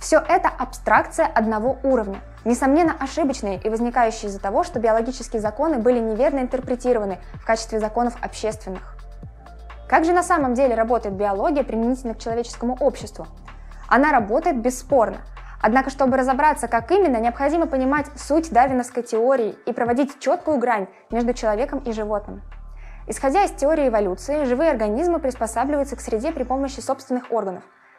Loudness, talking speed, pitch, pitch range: -21 LUFS, 140 wpm, 250 Hz, 225-280 Hz